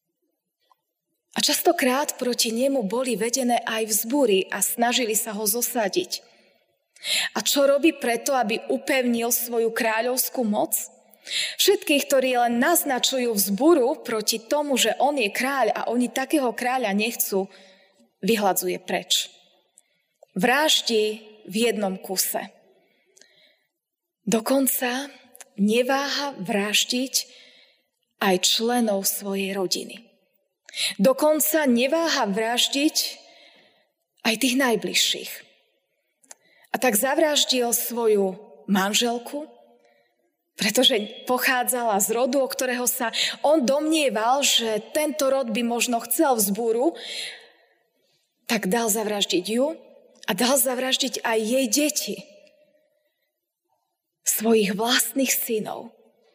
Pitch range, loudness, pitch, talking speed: 220-275 Hz, -22 LUFS, 245 Hz, 95 wpm